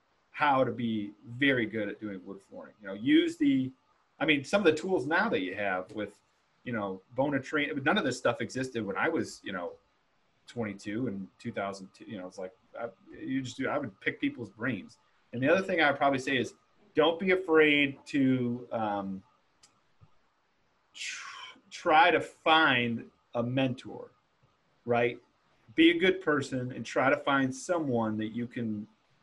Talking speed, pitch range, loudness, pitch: 180 wpm, 105-145 Hz, -29 LUFS, 125 Hz